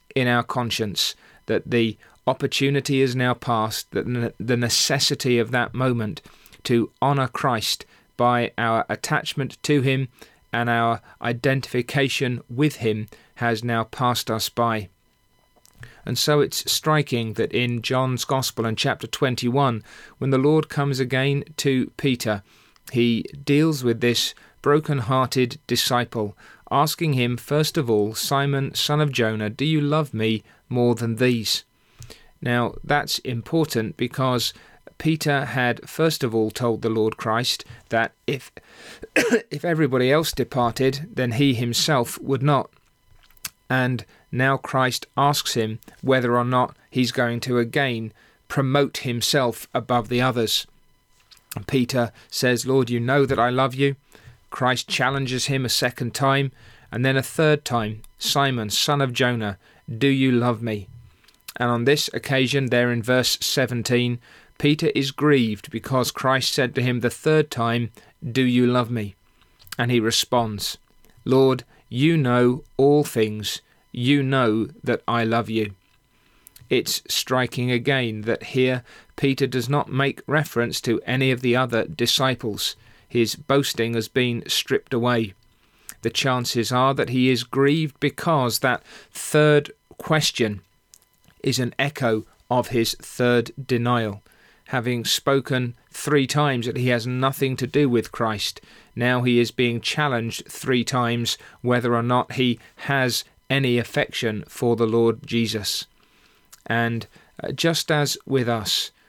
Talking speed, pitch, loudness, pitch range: 140 wpm, 125 Hz, -22 LUFS, 115-135 Hz